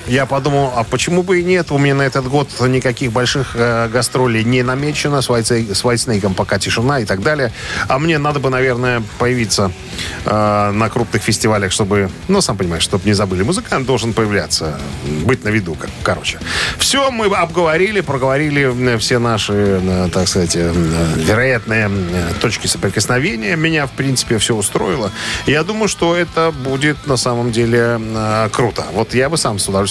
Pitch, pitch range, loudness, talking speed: 120 Hz, 105-140 Hz, -15 LUFS, 170 wpm